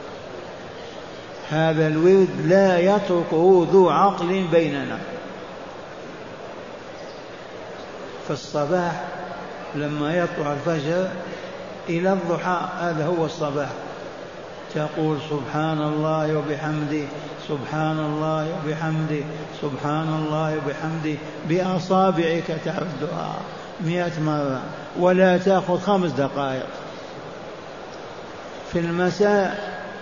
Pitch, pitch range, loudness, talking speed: 160 Hz, 150-180 Hz, -22 LUFS, 75 wpm